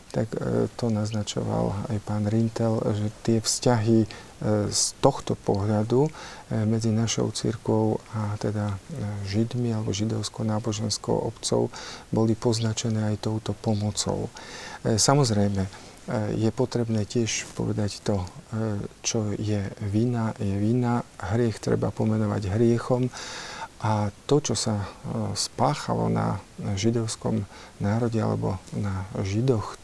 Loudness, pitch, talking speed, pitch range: -26 LUFS, 110 Hz, 105 wpm, 105-115 Hz